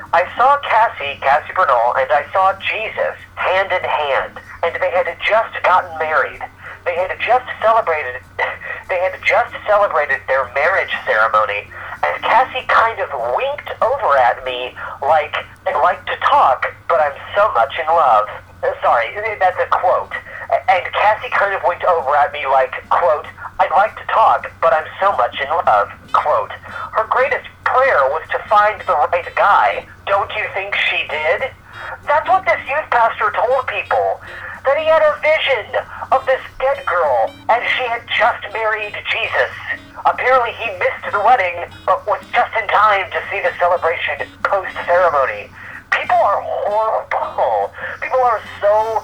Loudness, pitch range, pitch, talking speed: -16 LUFS, 185-270 Hz, 220 Hz, 160 wpm